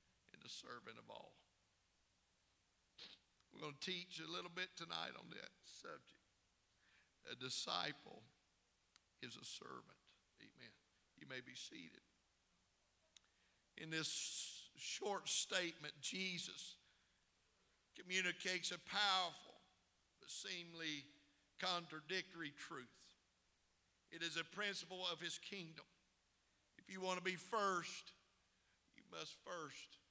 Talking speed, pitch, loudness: 105 wpm, 165 Hz, -46 LUFS